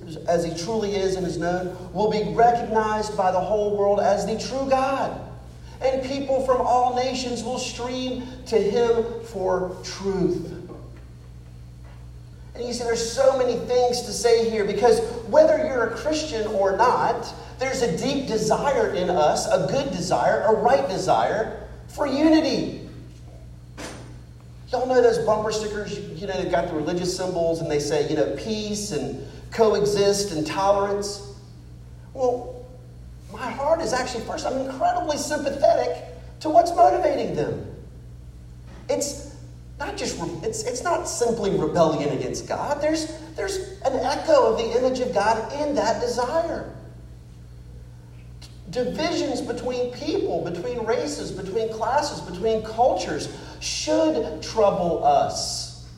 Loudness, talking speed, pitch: -23 LUFS, 140 wpm, 210 Hz